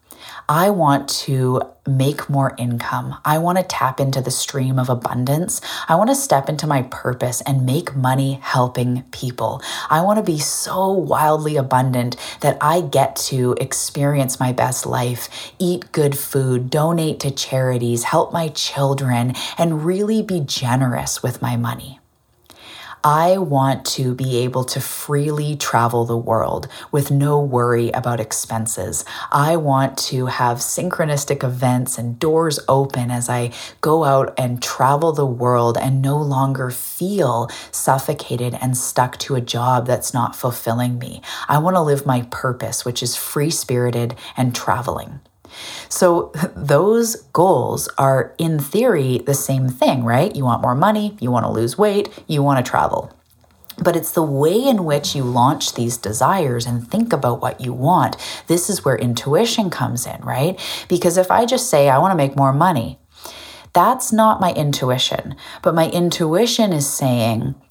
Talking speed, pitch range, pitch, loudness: 160 wpm, 125-155 Hz, 135 Hz, -18 LUFS